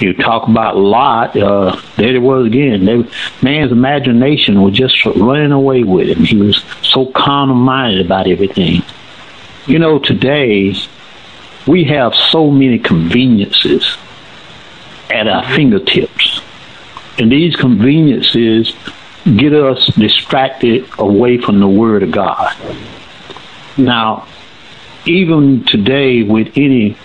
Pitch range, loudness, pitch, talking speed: 105-135 Hz, -10 LUFS, 125 Hz, 120 wpm